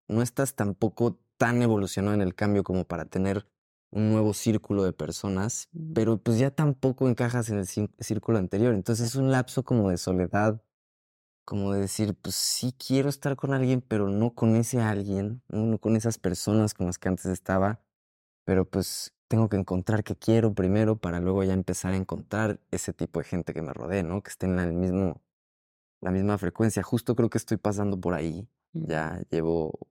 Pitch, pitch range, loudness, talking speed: 105 Hz, 95-115 Hz, -27 LUFS, 190 wpm